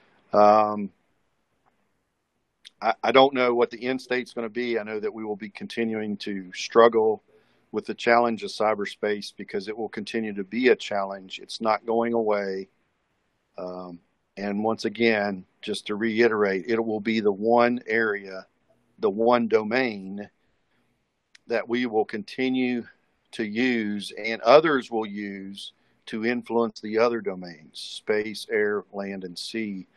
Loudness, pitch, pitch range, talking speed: -25 LUFS, 110 Hz, 100-115 Hz, 150 wpm